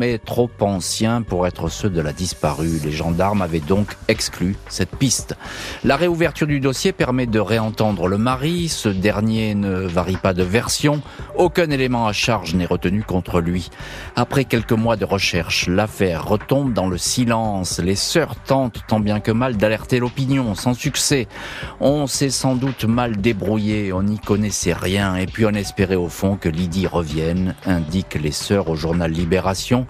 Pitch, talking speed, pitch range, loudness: 105 Hz, 175 wpm, 90-120 Hz, -19 LUFS